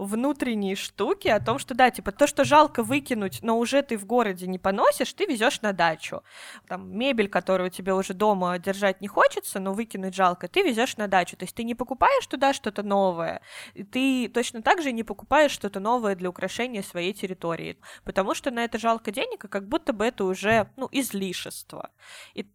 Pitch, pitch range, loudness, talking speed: 220 Hz, 195-265 Hz, -25 LUFS, 195 wpm